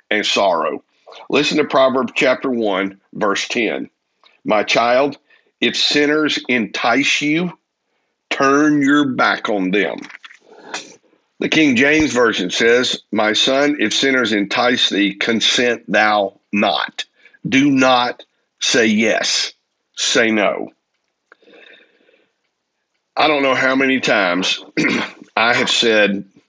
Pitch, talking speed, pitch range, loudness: 135 Hz, 110 wpm, 110-150 Hz, -15 LUFS